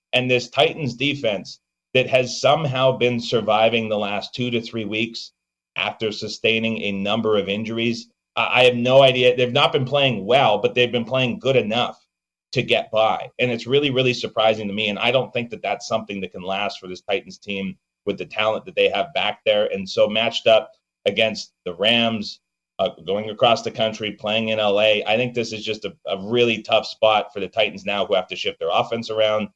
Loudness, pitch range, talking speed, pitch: -20 LUFS, 105-125 Hz, 210 wpm, 115 Hz